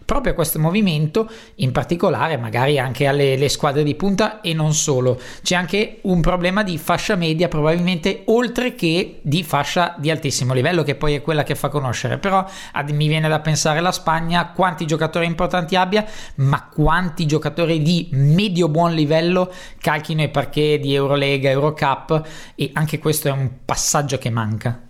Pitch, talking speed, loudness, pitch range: 160 Hz, 170 wpm, -19 LUFS, 145-180 Hz